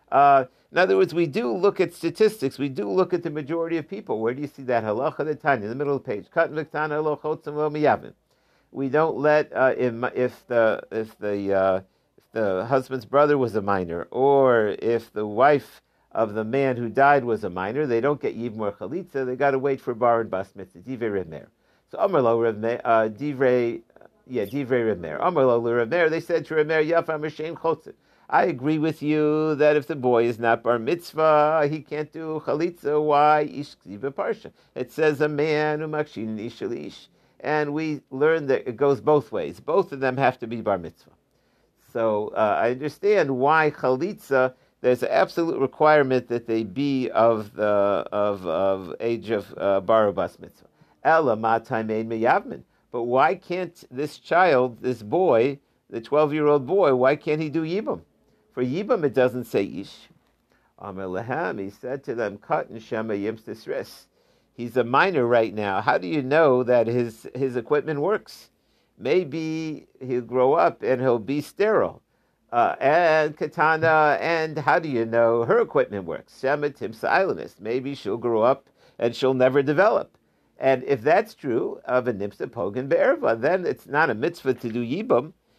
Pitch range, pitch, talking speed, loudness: 115-150 Hz, 135 Hz, 165 wpm, -23 LUFS